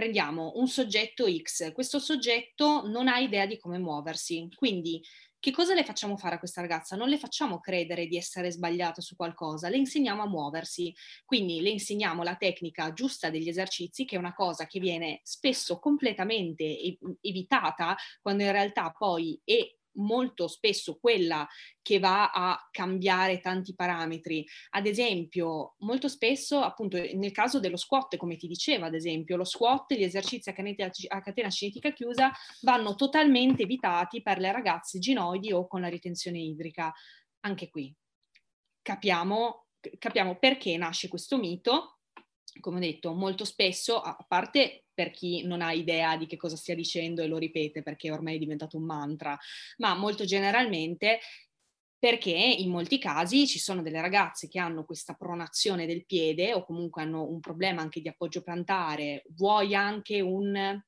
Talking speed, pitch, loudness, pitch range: 165 wpm, 185 Hz, -29 LUFS, 170-225 Hz